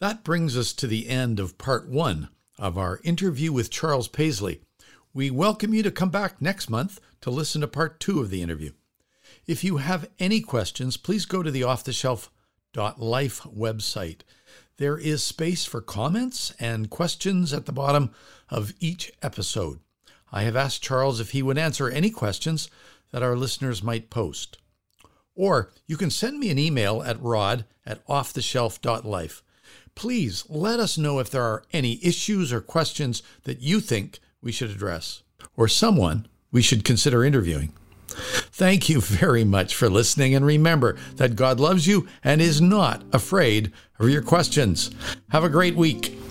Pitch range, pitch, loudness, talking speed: 115-165 Hz, 130 Hz, -24 LUFS, 165 wpm